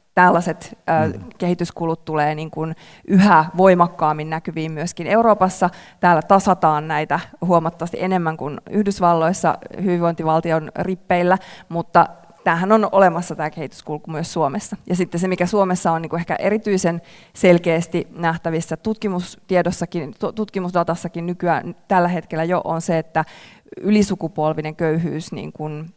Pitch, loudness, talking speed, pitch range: 170 Hz, -19 LUFS, 120 wpm, 160-185 Hz